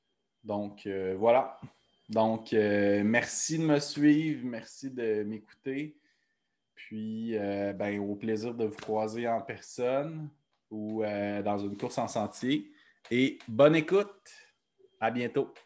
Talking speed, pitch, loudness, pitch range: 130 wpm, 115 Hz, -30 LUFS, 105-145 Hz